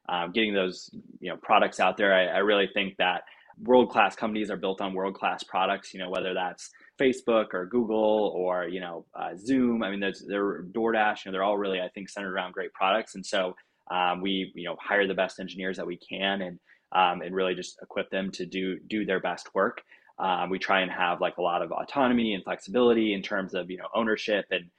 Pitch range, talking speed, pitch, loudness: 95-110 Hz, 225 wpm, 95 Hz, -27 LUFS